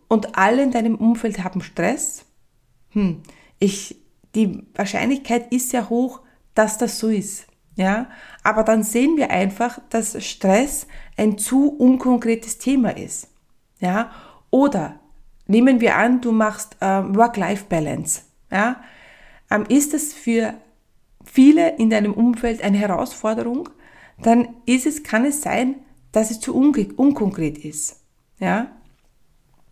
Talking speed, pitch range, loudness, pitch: 130 wpm, 205-250 Hz, -19 LUFS, 230 Hz